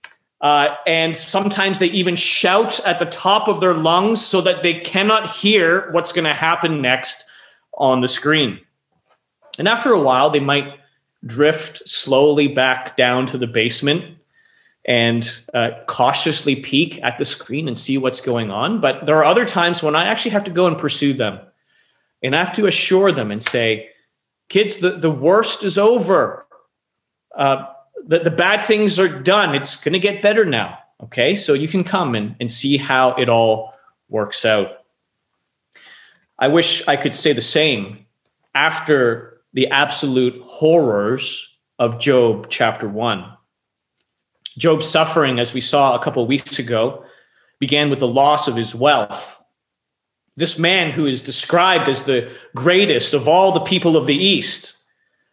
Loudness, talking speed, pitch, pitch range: -16 LUFS, 165 wpm, 150 Hz, 130-180 Hz